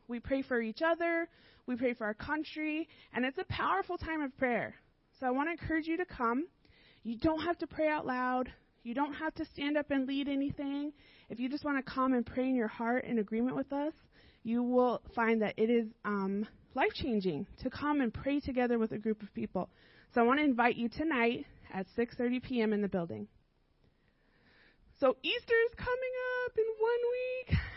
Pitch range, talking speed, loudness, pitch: 235-310 Hz, 205 wpm, -34 LUFS, 260 Hz